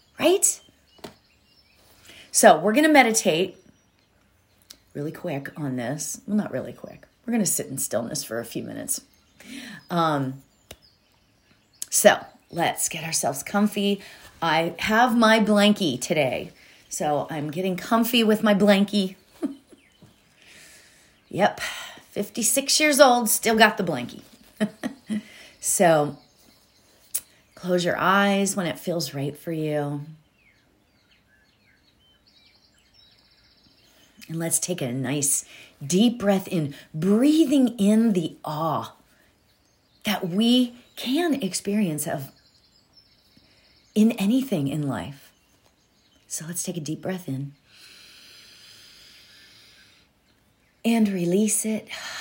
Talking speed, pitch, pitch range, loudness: 105 wpm, 185 Hz, 145-220 Hz, -23 LUFS